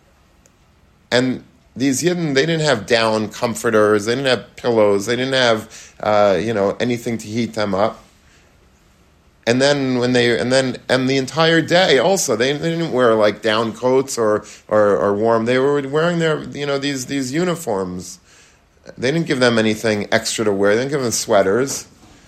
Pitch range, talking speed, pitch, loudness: 105-135 Hz, 180 wpm, 115 Hz, -17 LUFS